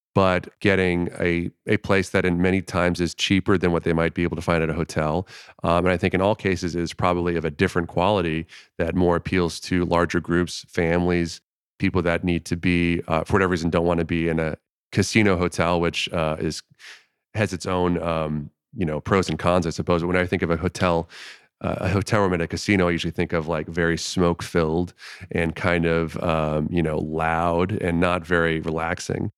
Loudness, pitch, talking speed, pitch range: -23 LUFS, 85 Hz, 215 wpm, 85-90 Hz